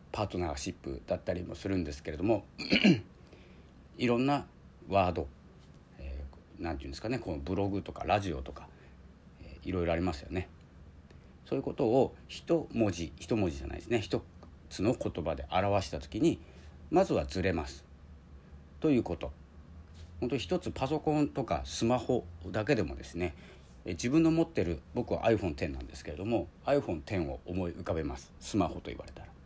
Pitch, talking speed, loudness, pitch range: 85 Hz, 360 characters per minute, -33 LUFS, 75-100 Hz